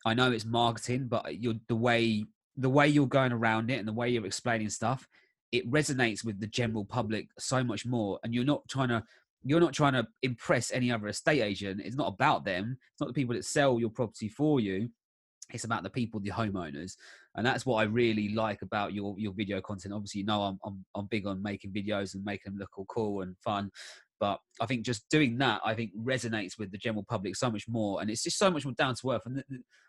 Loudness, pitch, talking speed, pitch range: -31 LUFS, 115 Hz, 240 wpm, 105-125 Hz